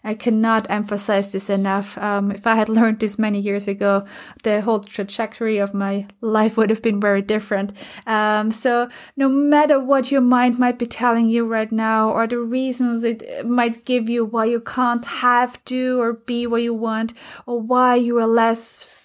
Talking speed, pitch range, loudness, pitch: 190 wpm, 215-245 Hz, -19 LUFS, 230 Hz